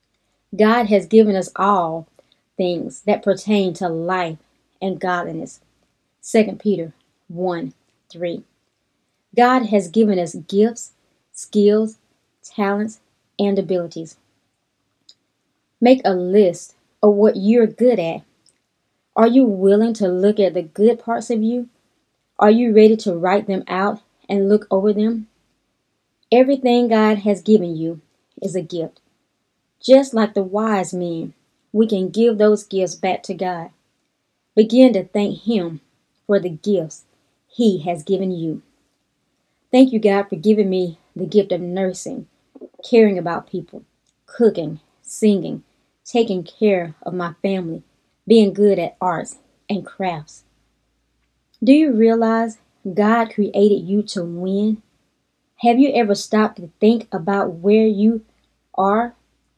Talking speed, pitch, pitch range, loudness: 130 wpm, 200 Hz, 180-220 Hz, -18 LUFS